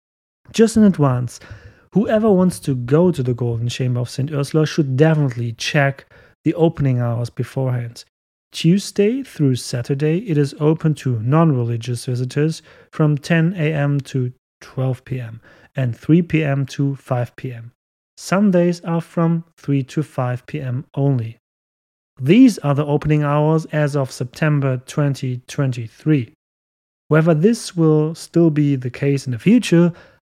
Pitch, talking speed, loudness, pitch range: 140 Hz, 140 wpm, -18 LUFS, 125-160 Hz